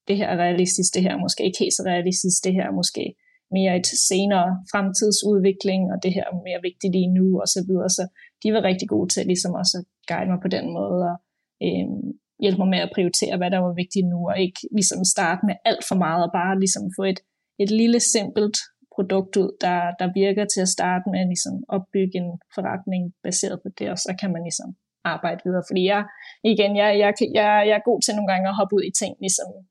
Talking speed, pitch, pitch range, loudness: 230 wpm, 190 Hz, 180-205 Hz, -22 LUFS